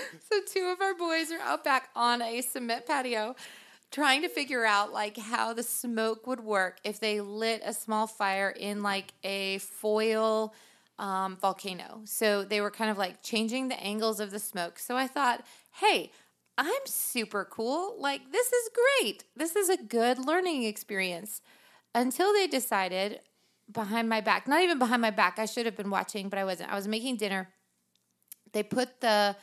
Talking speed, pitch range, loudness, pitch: 180 wpm, 205-260 Hz, -30 LUFS, 220 Hz